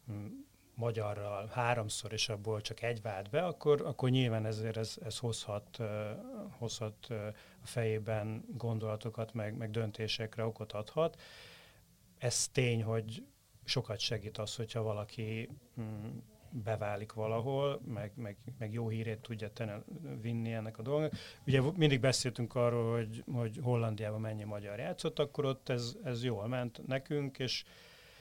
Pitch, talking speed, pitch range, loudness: 115 Hz, 140 wpm, 110-125 Hz, -37 LUFS